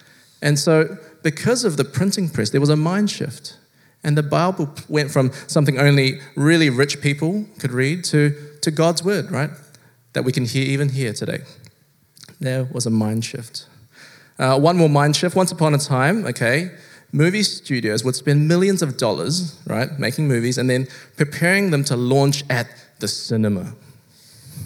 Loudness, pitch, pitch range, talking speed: -19 LUFS, 145 Hz, 130-165 Hz, 170 wpm